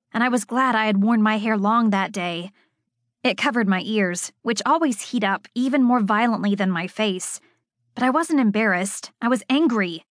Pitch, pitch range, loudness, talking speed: 220 Hz, 195-245 Hz, -21 LUFS, 195 wpm